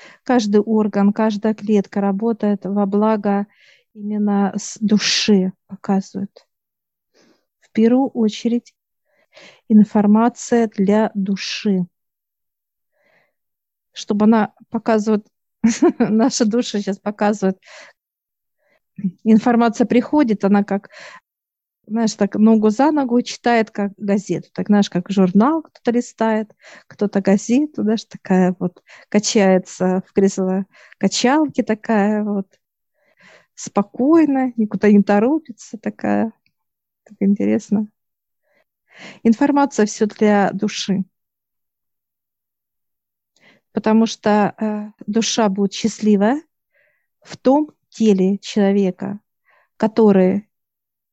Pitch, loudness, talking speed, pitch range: 210 Hz, -18 LUFS, 85 wpm, 200-230 Hz